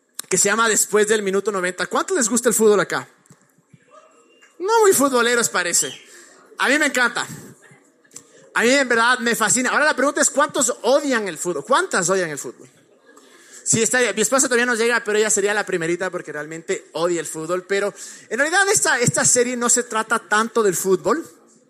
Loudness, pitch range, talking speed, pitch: -18 LUFS, 190-255 Hz, 190 wpm, 225 Hz